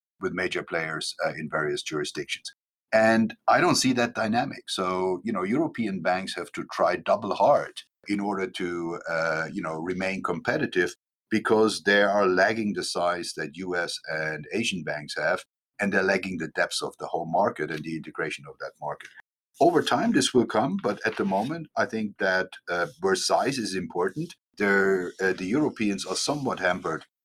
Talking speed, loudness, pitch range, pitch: 180 wpm, -26 LUFS, 90-110 Hz, 95 Hz